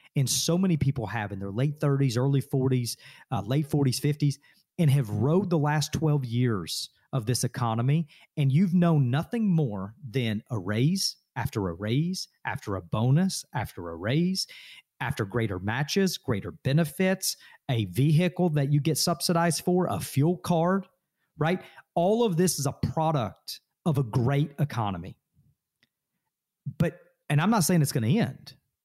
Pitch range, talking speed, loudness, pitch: 125-170 Hz, 160 wpm, -27 LUFS, 145 Hz